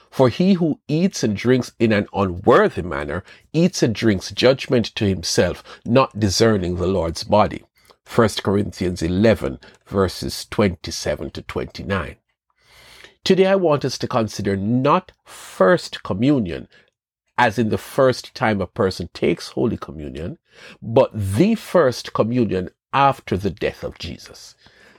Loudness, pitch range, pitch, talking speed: -20 LUFS, 95-130 Hz, 110 Hz, 135 wpm